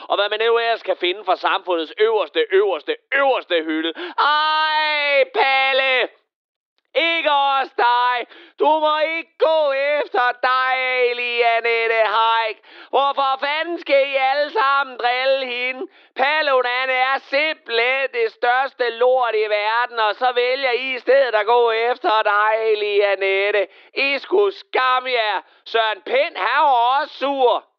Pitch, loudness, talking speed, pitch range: 255 Hz, -18 LUFS, 135 wpm, 230-280 Hz